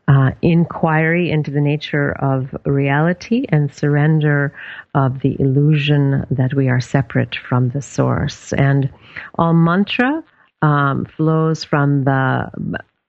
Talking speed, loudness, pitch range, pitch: 120 wpm, -17 LUFS, 135-160 Hz, 145 Hz